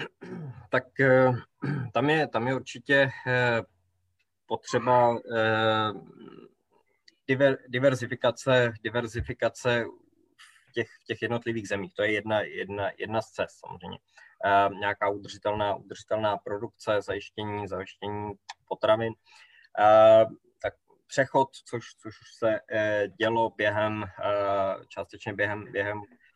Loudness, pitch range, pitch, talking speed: -27 LUFS, 105-125 Hz, 110 Hz, 85 wpm